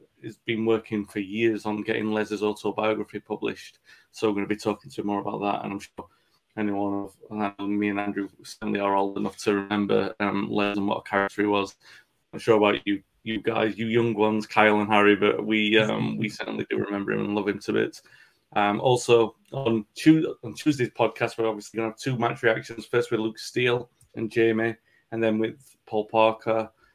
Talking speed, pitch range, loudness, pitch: 205 wpm, 100-115 Hz, -25 LUFS, 105 Hz